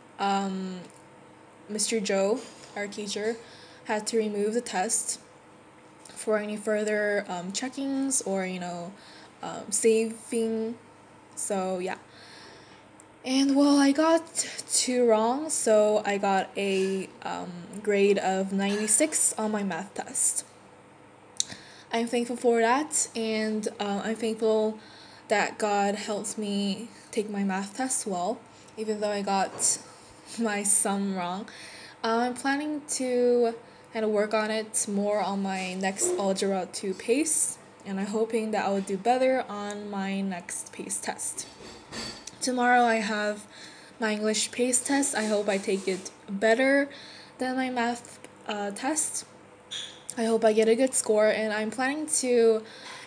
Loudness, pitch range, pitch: -27 LUFS, 200-235 Hz, 215 Hz